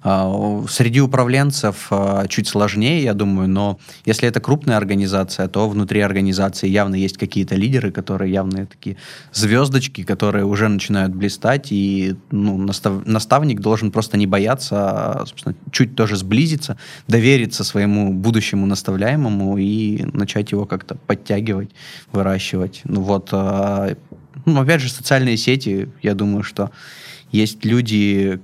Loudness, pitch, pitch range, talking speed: -18 LUFS, 105 Hz, 100-120 Hz, 135 wpm